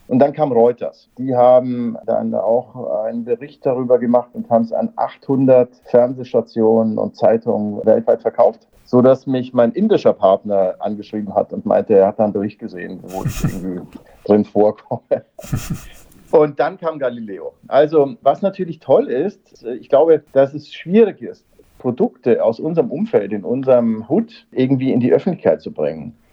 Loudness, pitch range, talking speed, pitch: -17 LUFS, 110-140 Hz, 160 wpm, 125 Hz